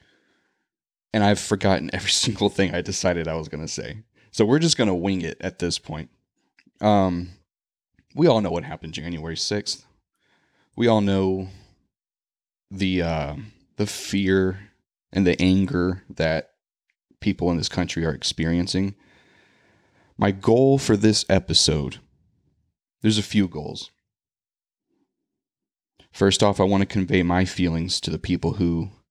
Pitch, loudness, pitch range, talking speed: 95 Hz, -22 LUFS, 85-100 Hz, 140 wpm